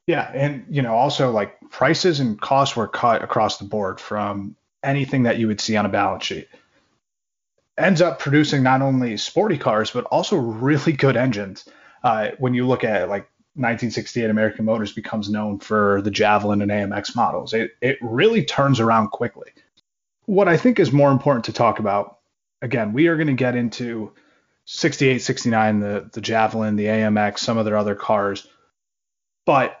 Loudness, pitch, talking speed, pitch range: -20 LUFS, 115 Hz, 175 wpm, 105-135 Hz